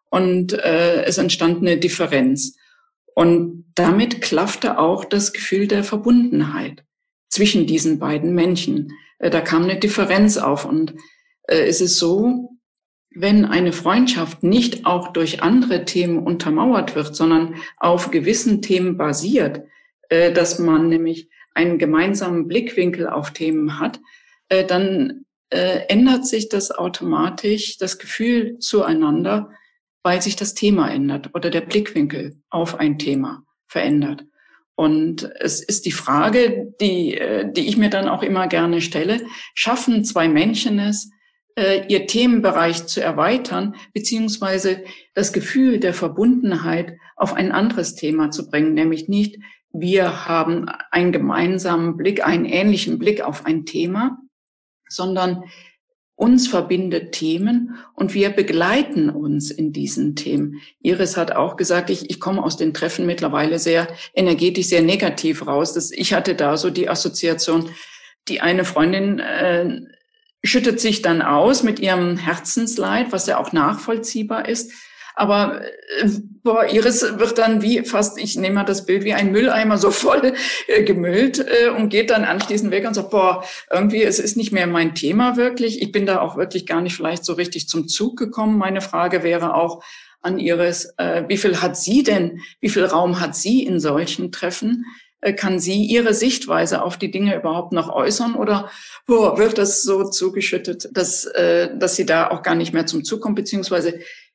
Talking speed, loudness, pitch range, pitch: 155 wpm, -18 LUFS, 170-225 Hz, 190 Hz